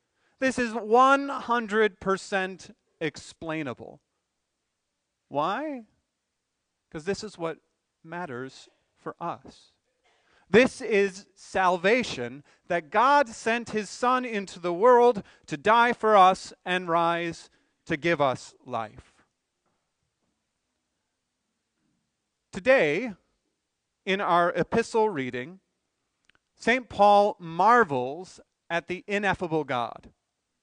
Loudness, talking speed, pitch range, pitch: -25 LUFS, 90 wpm, 170-230 Hz, 195 Hz